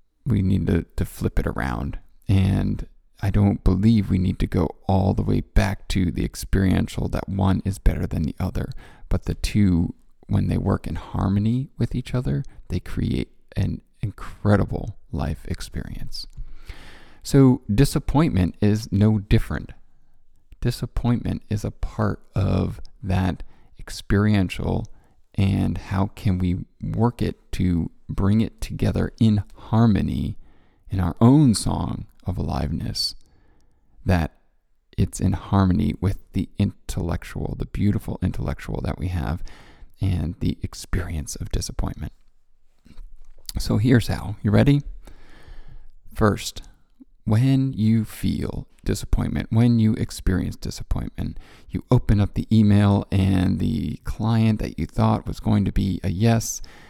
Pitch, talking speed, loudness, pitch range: 100 Hz, 130 wpm, -23 LUFS, 90-110 Hz